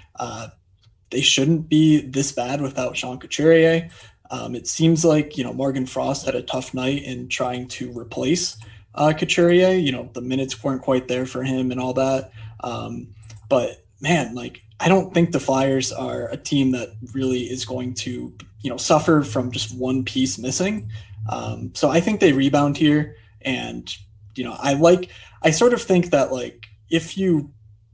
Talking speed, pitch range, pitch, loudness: 180 wpm, 120-150 Hz, 130 Hz, -21 LUFS